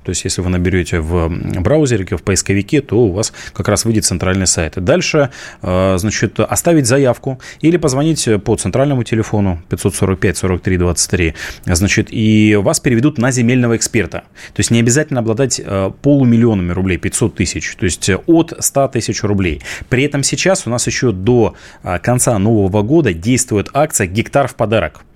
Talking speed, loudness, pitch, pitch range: 155 wpm, -14 LUFS, 110 Hz, 95-125 Hz